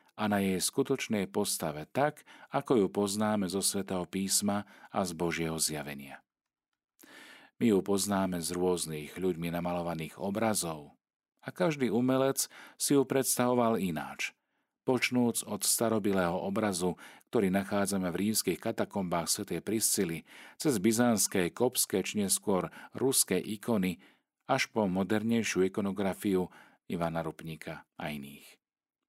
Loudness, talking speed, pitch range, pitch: -31 LUFS, 120 wpm, 90-115 Hz, 100 Hz